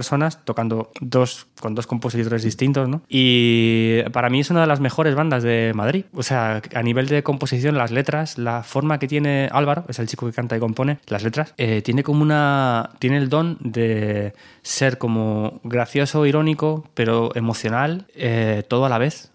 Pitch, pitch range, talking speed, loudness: 130 Hz, 115-145 Hz, 185 wpm, -20 LUFS